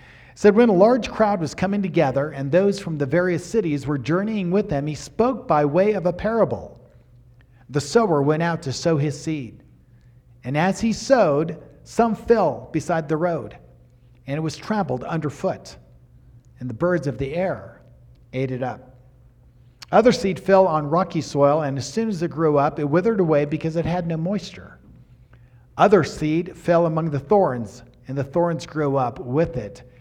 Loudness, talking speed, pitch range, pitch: -21 LUFS, 180 wpm, 125-185 Hz, 155 Hz